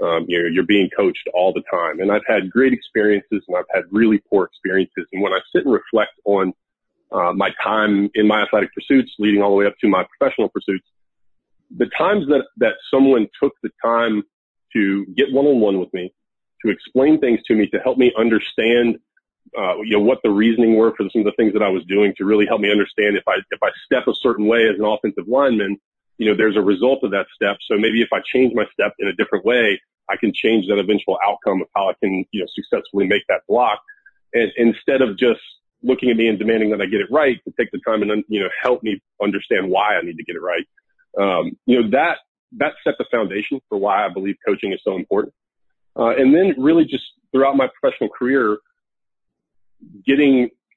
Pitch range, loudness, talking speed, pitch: 105-130 Hz, -18 LUFS, 225 wpm, 110 Hz